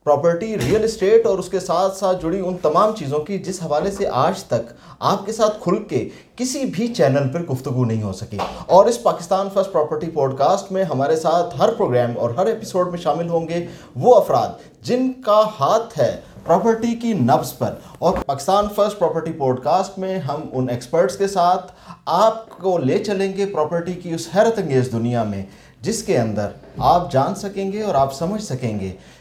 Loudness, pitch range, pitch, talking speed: -19 LUFS, 140-200 Hz, 175 Hz, 195 wpm